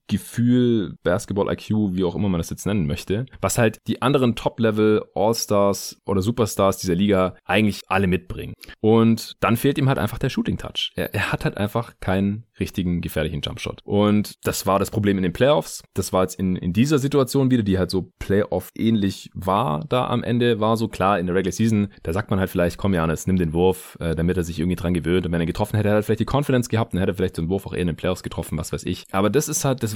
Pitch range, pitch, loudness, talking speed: 90-115 Hz, 100 Hz, -22 LUFS, 245 wpm